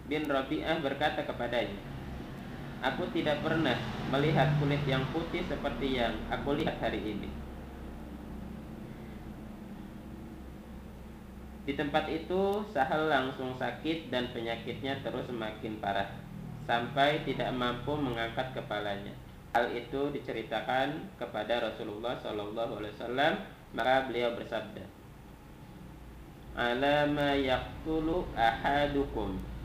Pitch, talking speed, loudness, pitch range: 130 Hz, 90 wpm, -32 LUFS, 115-145 Hz